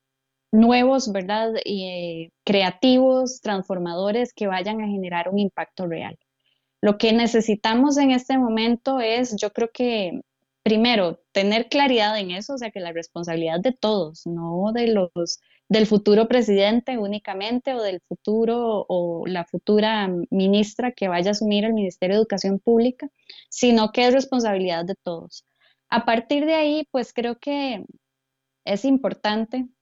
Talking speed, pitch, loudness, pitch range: 145 wpm, 210 Hz, -22 LUFS, 185-240 Hz